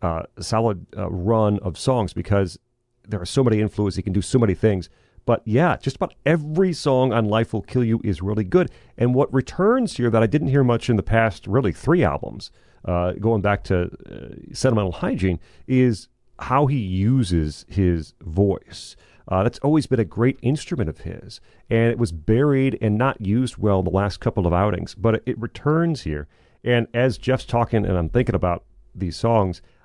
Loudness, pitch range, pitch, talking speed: -21 LUFS, 95-125 Hz, 110 Hz, 195 wpm